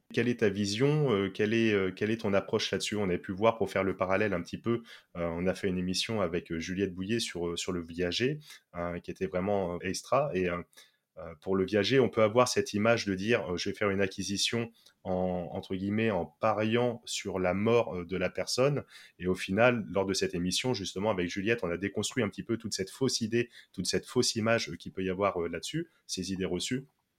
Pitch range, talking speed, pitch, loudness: 90-115 Hz, 215 wpm, 100 Hz, -31 LUFS